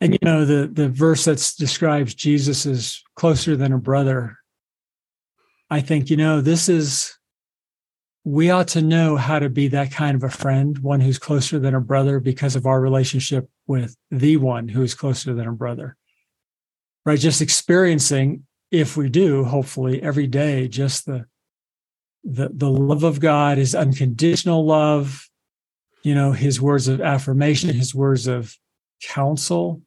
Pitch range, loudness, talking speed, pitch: 135-155 Hz, -19 LUFS, 160 wpm, 140 Hz